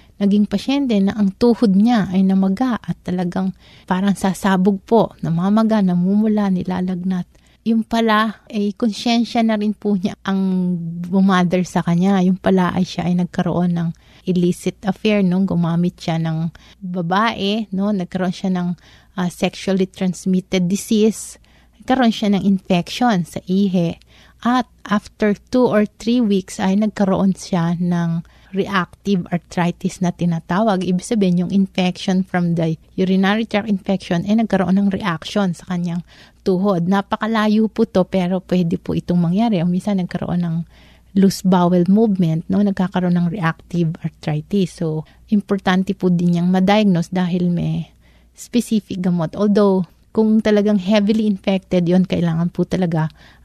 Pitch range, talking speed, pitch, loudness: 175-205 Hz, 145 wpm, 190 Hz, -18 LUFS